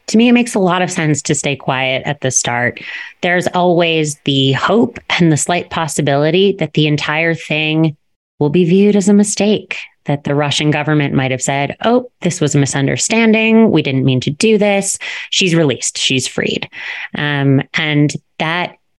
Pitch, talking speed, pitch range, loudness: 155 Hz, 180 wpm, 140-185 Hz, -14 LUFS